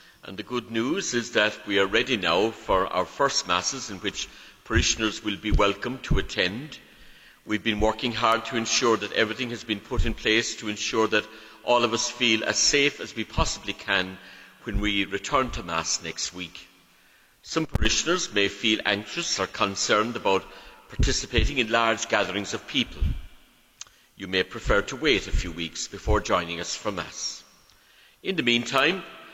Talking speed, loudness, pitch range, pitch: 175 wpm, -25 LUFS, 100-120 Hz, 110 Hz